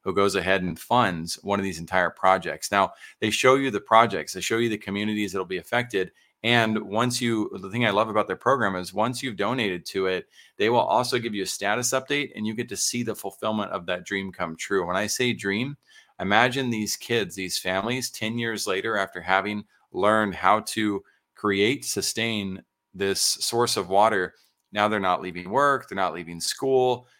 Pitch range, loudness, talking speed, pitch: 95-120 Hz, -25 LUFS, 205 wpm, 105 Hz